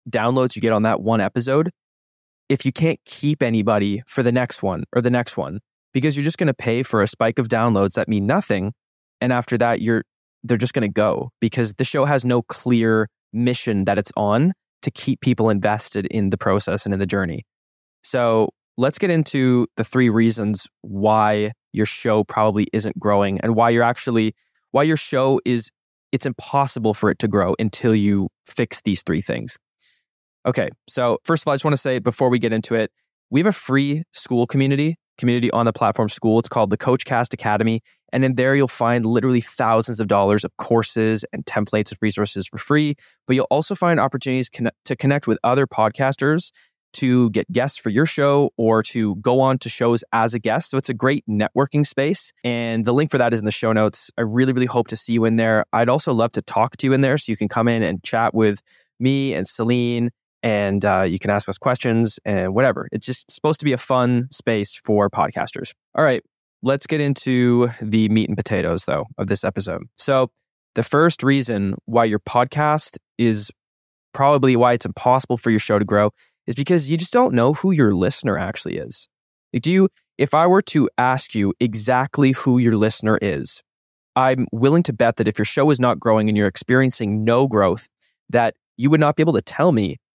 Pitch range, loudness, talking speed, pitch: 110-135 Hz, -20 LUFS, 210 wpm, 120 Hz